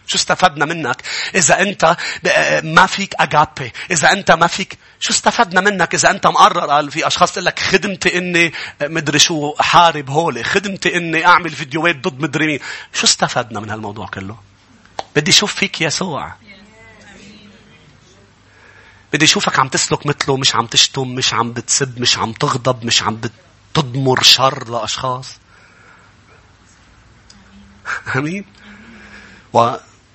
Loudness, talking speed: -14 LUFS, 135 wpm